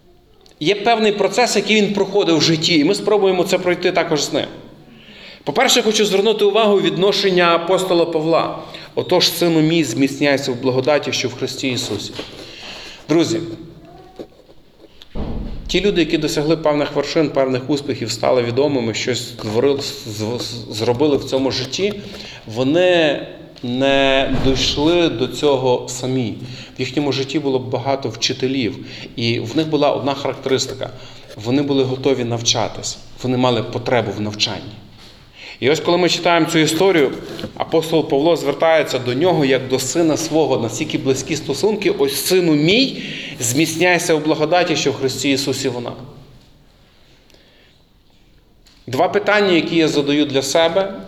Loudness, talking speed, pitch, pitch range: -17 LUFS, 135 wpm, 145 Hz, 130-170 Hz